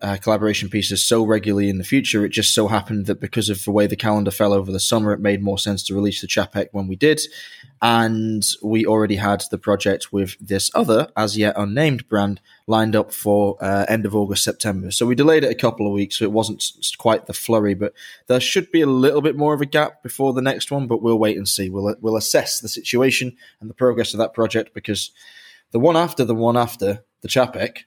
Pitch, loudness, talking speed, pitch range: 110 Hz, -19 LUFS, 235 wpm, 100-120 Hz